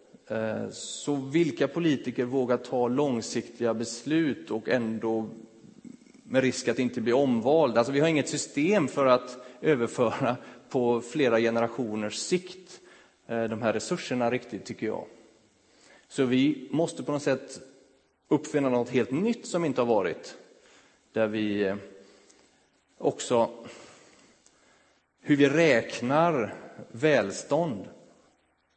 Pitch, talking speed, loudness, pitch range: 125 Hz, 115 wpm, -27 LUFS, 115-145 Hz